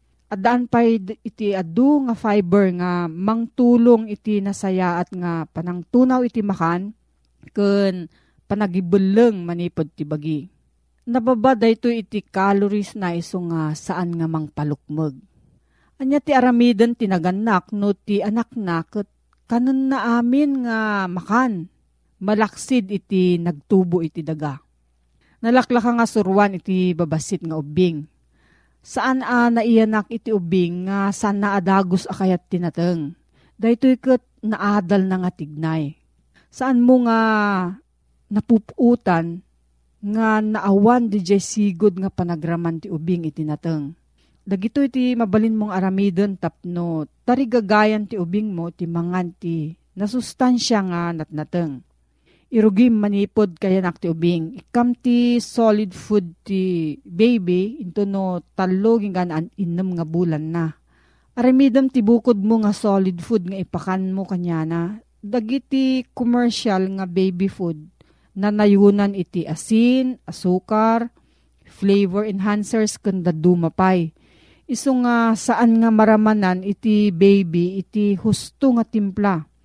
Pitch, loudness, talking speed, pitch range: 200 Hz, -19 LUFS, 120 wpm, 175-225 Hz